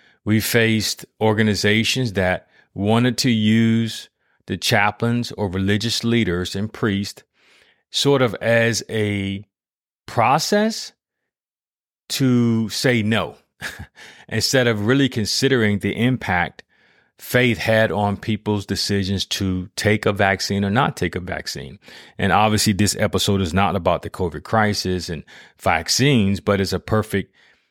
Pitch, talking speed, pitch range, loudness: 105 Hz, 125 wpm, 100-115 Hz, -19 LUFS